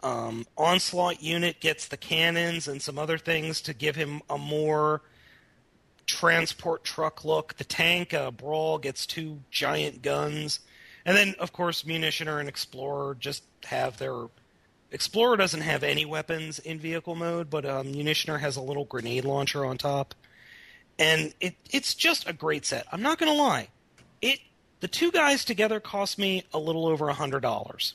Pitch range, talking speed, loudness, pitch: 145-170 Hz, 170 wpm, -27 LUFS, 155 Hz